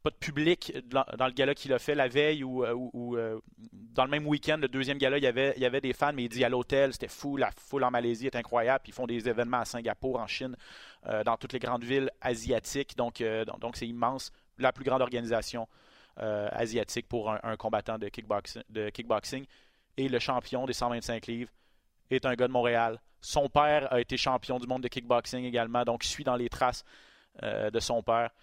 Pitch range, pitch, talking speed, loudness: 115-135 Hz, 125 Hz, 220 wpm, -31 LUFS